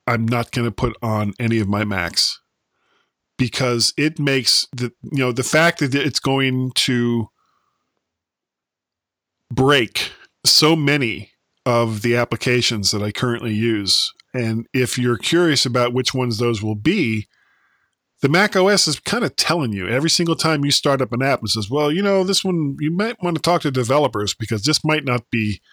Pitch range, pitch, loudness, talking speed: 115-150 Hz, 125 Hz, -18 LUFS, 180 wpm